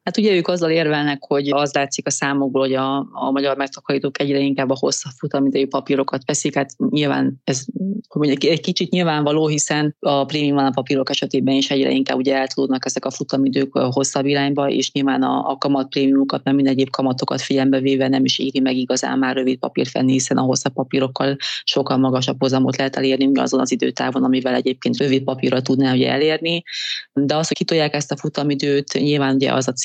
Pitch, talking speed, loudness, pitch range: 135 Hz, 195 wpm, -19 LUFS, 135-145 Hz